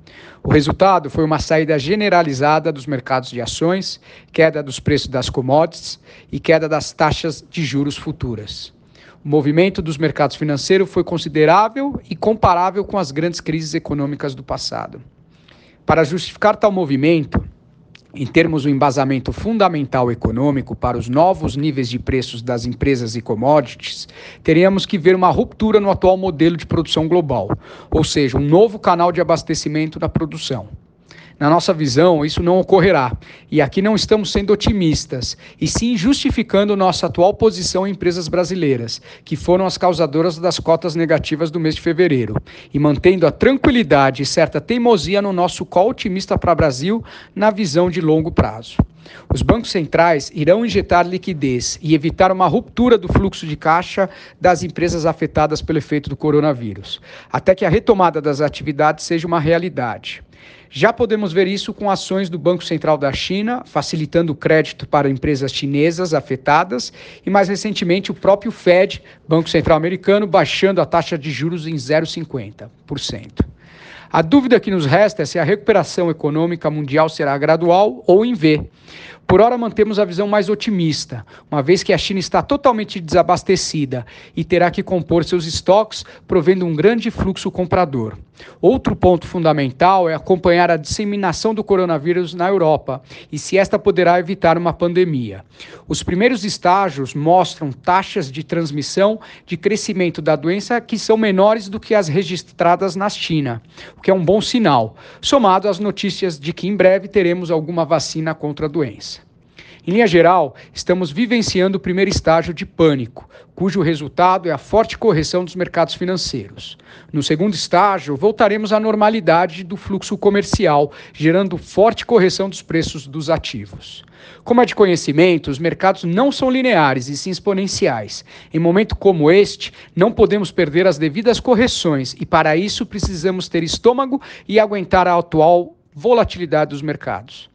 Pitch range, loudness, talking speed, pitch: 150-195 Hz, -16 LUFS, 155 wpm, 175 Hz